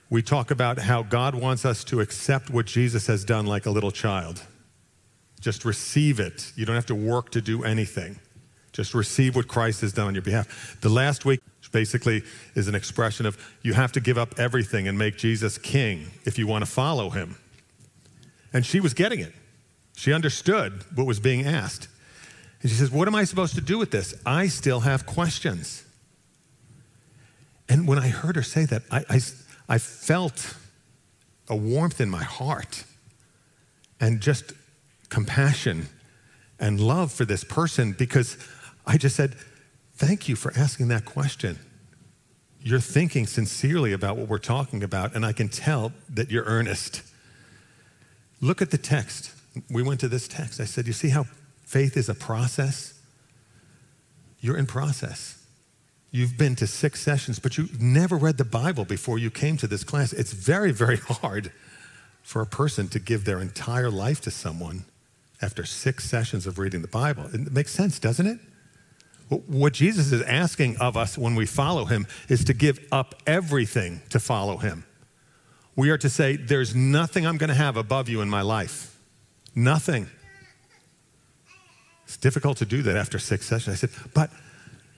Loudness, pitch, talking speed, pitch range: -25 LUFS, 125 Hz, 175 wpm, 110-140 Hz